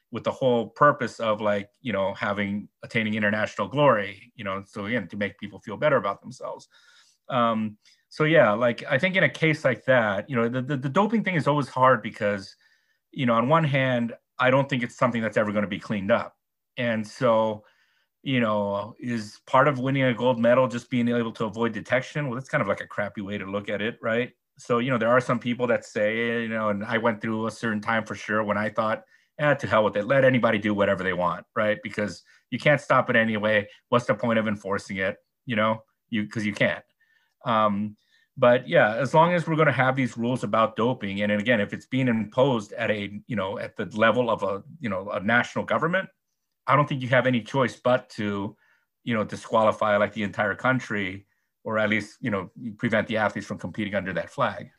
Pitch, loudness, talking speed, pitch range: 115 Hz, -25 LUFS, 230 wpm, 105-130 Hz